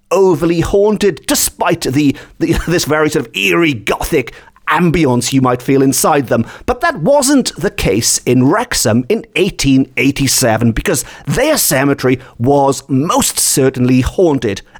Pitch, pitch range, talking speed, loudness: 140 Hz, 130-175 Hz, 135 wpm, -13 LUFS